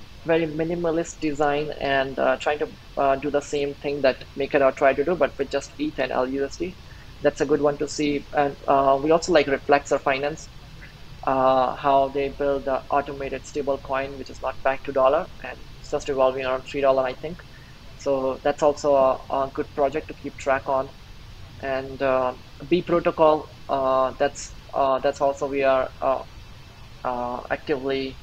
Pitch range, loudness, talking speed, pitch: 130-145 Hz, -24 LUFS, 180 wpm, 140 Hz